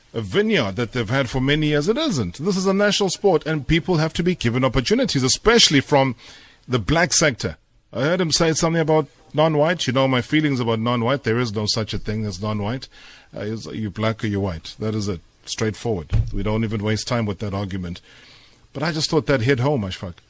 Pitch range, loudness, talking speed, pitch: 110-155 Hz, -20 LUFS, 230 wpm, 125 Hz